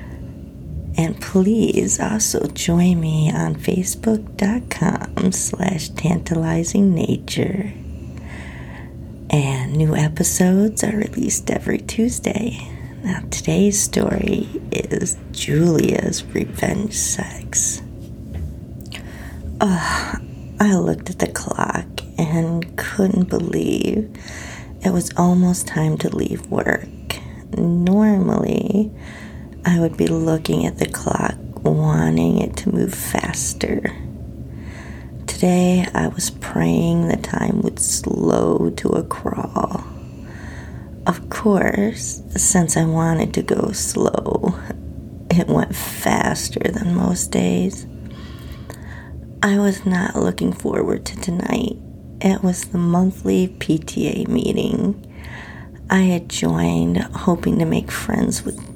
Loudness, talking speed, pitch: -19 LUFS, 100 wpm, 170 Hz